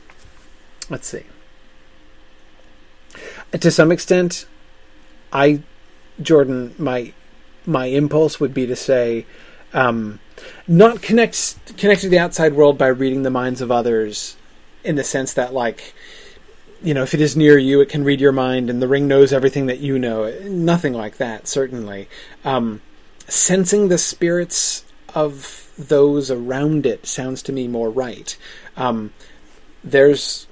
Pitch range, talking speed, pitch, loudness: 115-160 Hz, 145 wpm, 135 Hz, -17 LUFS